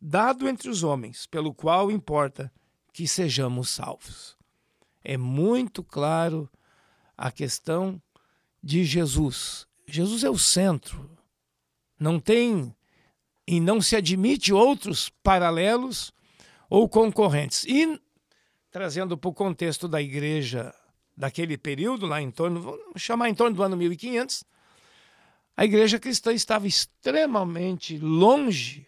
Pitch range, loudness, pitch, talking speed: 150-215 Hz, -24 LUFS, 180 Hz, 115 wpm